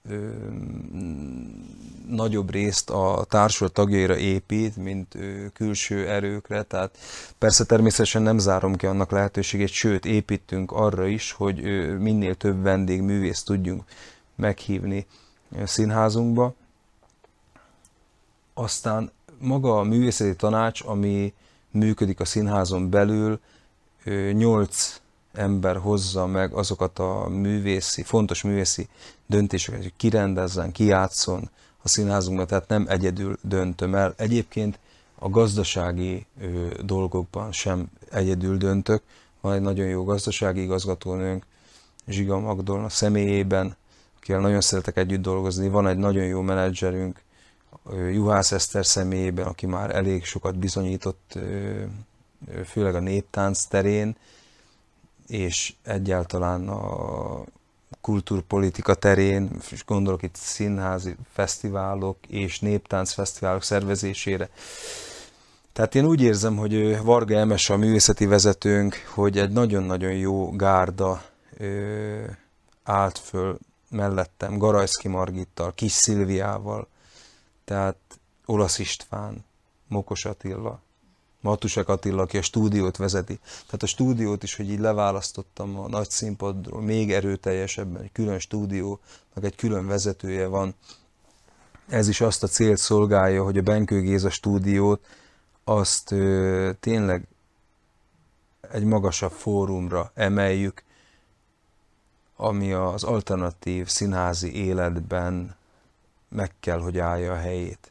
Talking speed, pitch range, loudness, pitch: 105 wpm, 95-105 Hz, -24 LUFS, 100 Hz